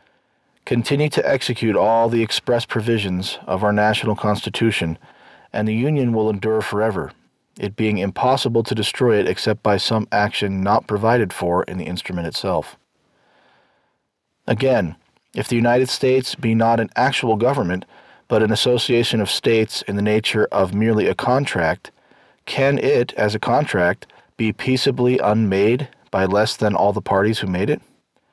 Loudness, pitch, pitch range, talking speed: -19 LUFS, 110 Hz, 105-125 Hz, 155 wpm